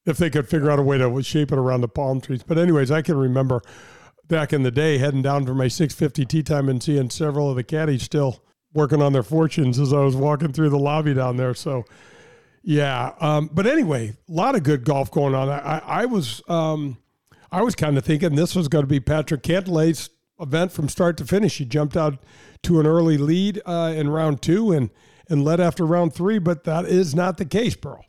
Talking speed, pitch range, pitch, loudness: 235 wpm, 140-165 Hz, 150 Hz, -21 LUFS